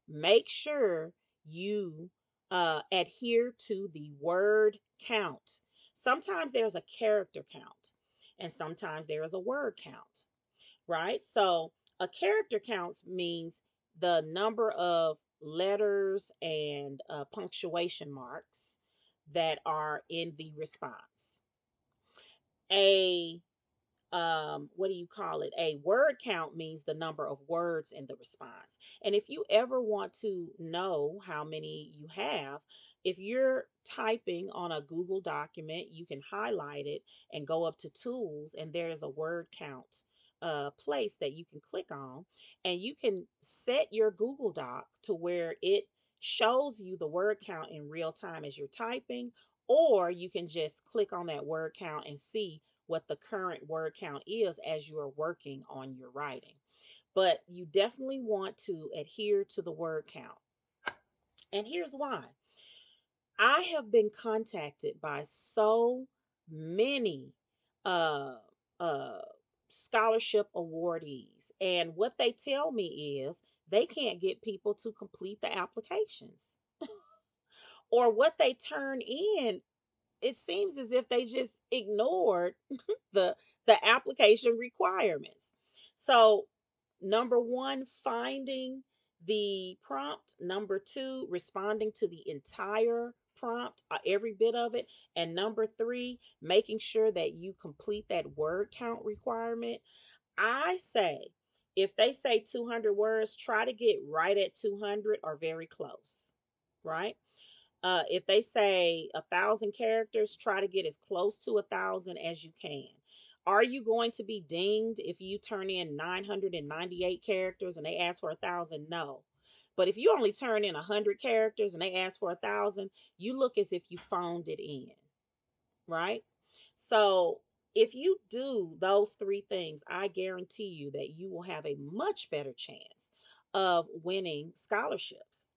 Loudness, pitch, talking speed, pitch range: -33 LUFS, 200 Hz, 145 wpm, 170-230 Hz